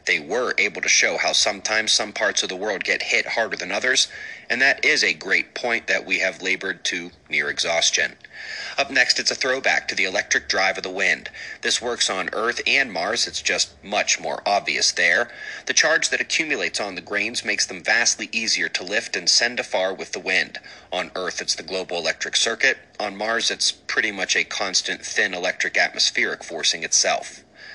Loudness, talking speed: -20 LUFS, 200 wpm